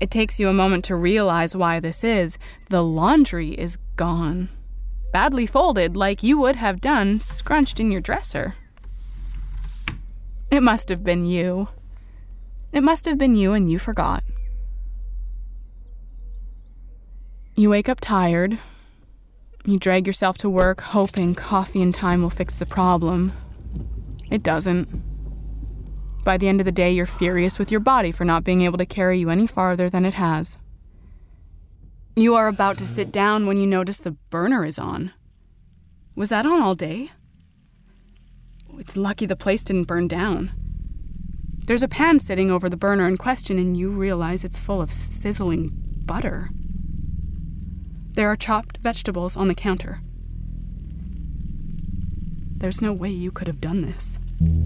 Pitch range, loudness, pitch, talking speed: 165-205 Hz, -21 LUFS, 185 Hz, 150 wpm